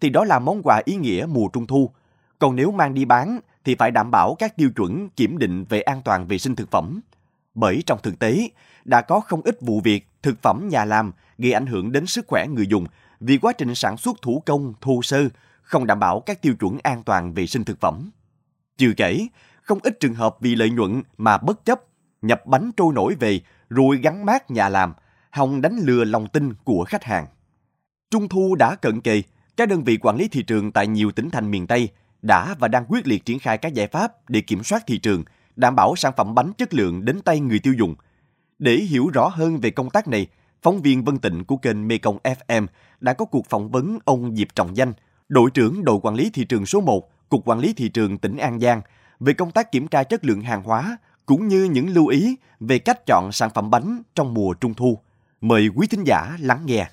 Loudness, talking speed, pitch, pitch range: -20 LUFS, 235 wpm, 120 Hz, 110-145 Hz